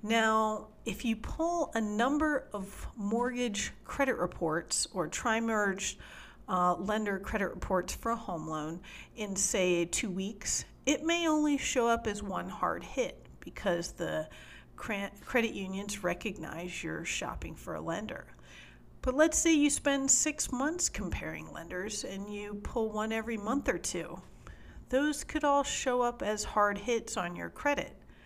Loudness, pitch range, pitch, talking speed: -32 LUFS, 195-265 Hz, 220 Hz, 150 wpm